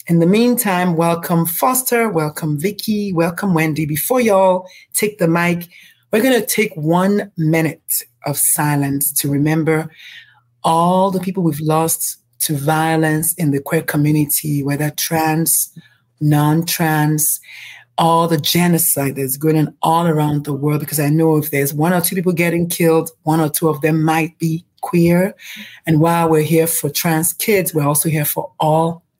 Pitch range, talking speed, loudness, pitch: 150-175 Hz, 160 wpm, -16 LUFS, 160 Hz